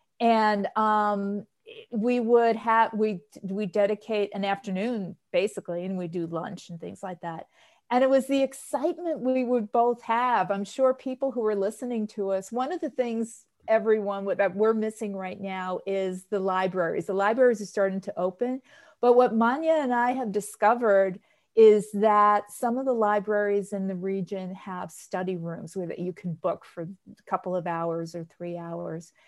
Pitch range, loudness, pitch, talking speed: 190-235 Hz, -26 LUFS, 205 Hz, 180 wpm